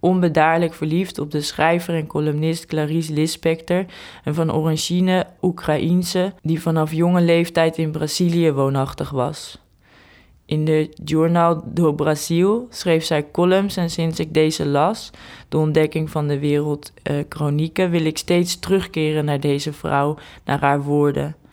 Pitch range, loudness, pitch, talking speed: 150-170 Hz, -20 LUFS, 160 Hz, 140 wpm